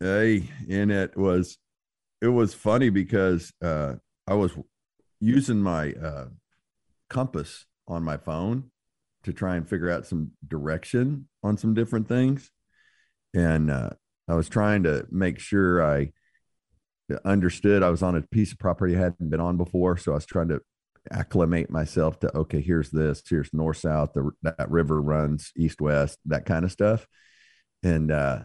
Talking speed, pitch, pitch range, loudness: 160 wpm, 90 Hz, 80-105 Hz, -26 LUFS